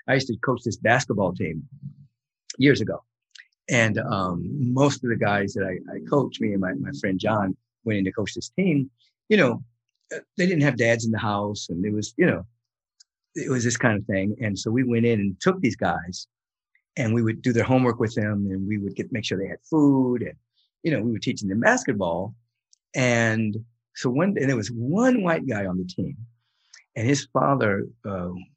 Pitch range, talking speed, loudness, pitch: 105-130 Hz, 210 wpm, -24 LUFS, 115 Hz